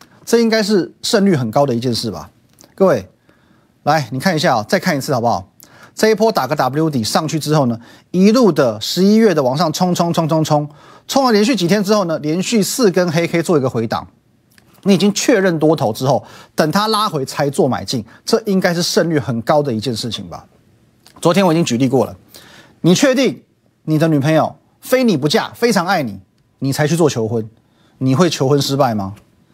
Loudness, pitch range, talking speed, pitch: -15 LUFS, 125-190 Hz, 295 characters per minute, 155 Hz